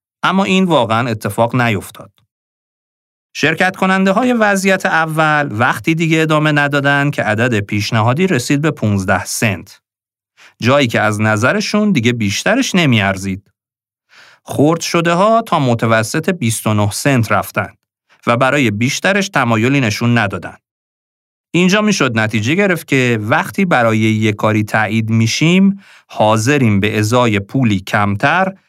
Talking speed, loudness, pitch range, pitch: 120 wpm, -14 LUFS, 110-165 Hz, 125 Hz